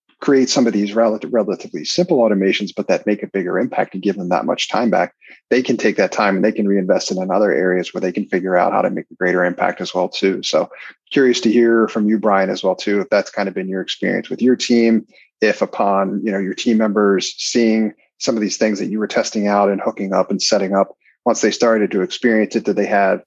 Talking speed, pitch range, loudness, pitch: 260 wpm, 95-115 Hz, -17 LUFS, 105 Hz